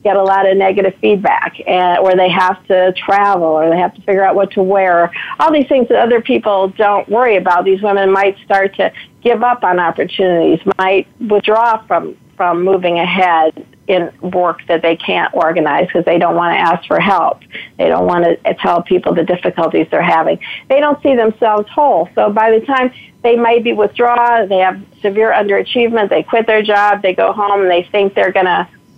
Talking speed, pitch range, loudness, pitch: 205 wpm, 185-225 Hz, -12 LUFS, 195 Hz